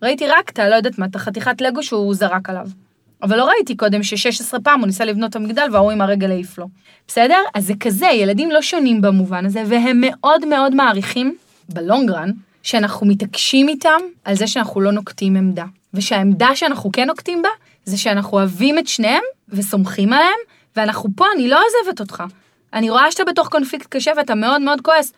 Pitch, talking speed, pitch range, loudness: 225 Hz, 190 wpm, 200-290 Hz, -16 LUFS